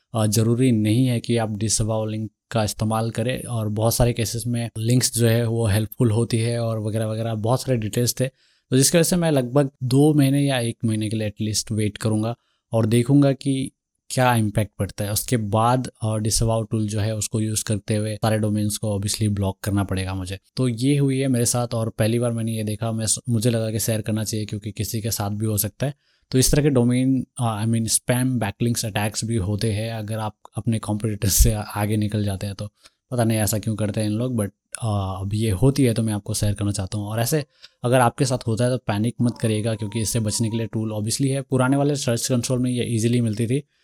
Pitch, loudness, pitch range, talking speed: 115 Hz, -22 LUFS, 110-125 Hz, 230 wpm